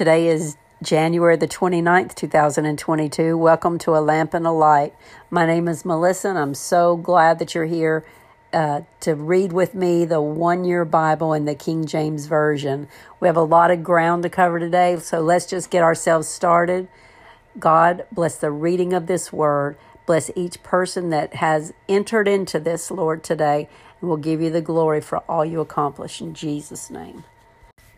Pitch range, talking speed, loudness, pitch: 155-175 Hz, 175 wpm, -19 LUFS, 165 Hz